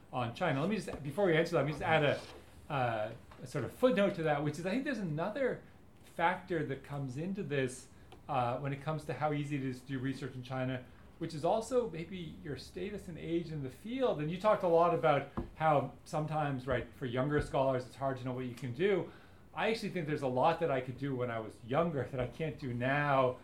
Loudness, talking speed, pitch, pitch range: -35 LUFS, 245 wpm, 145 Hz, 130-170 Hz